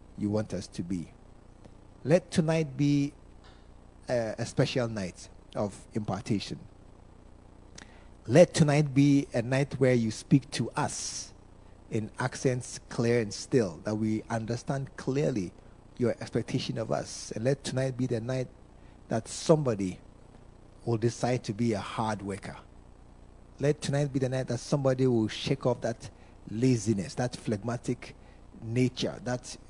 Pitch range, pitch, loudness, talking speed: 100-130 Hz, 115 Hz, -30 LUFS, 135 wpm